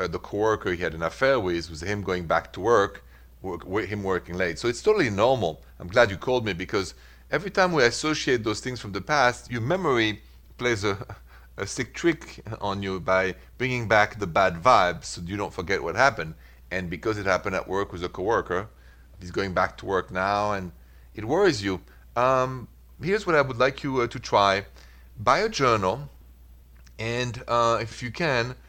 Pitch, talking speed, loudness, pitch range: 100 Hz, 200 wpm, -25 LUFS, 80-120 Hz